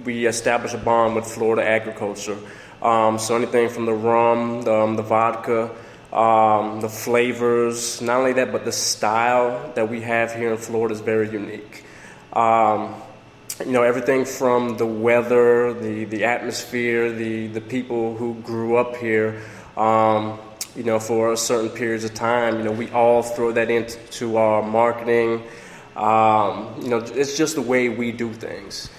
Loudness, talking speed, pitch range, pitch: -20 LUFS, 165 wpm, 110-120 Hz, 115 Hz